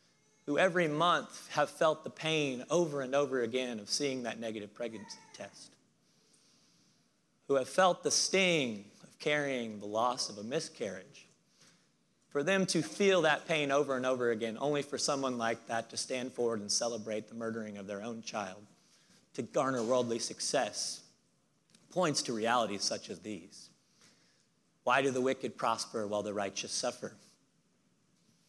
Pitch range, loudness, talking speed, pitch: 115-150 Hz, -33 LUFS, 155 wpm, 130 Hz